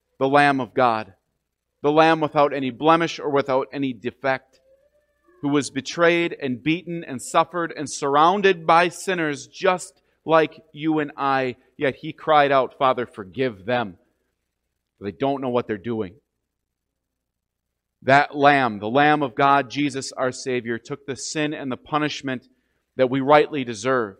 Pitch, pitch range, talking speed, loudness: 140 Hz, 125-155 Hz, 150 wpm, -21 LUFS